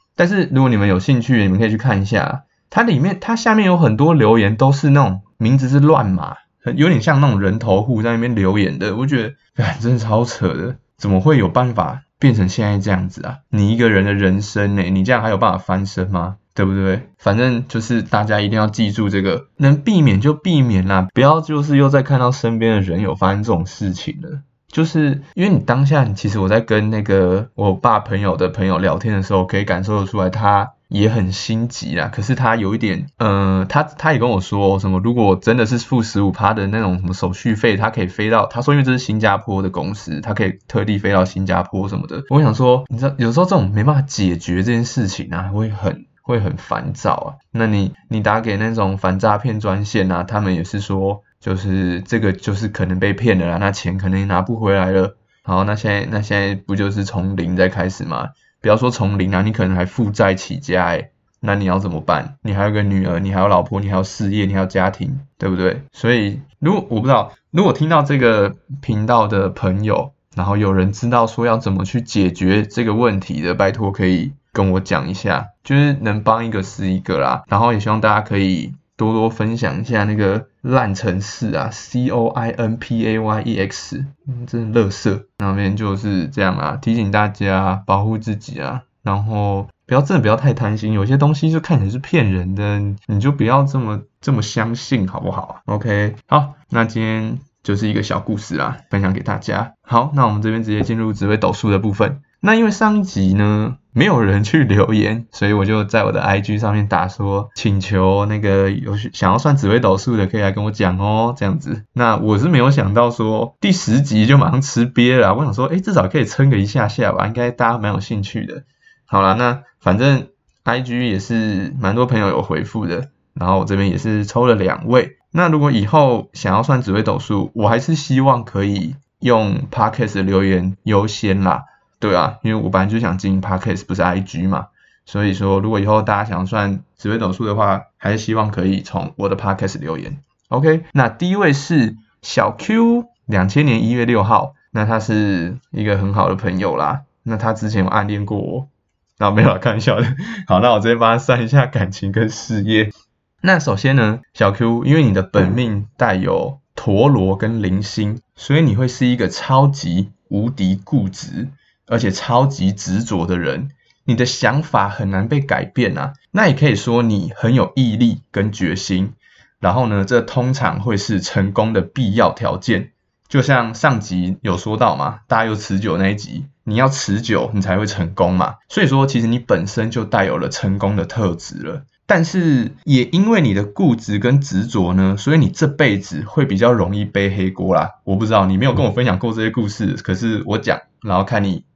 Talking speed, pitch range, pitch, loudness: 310 characters per minute, 95-125 Hz, 110 Hz, -17 LUFS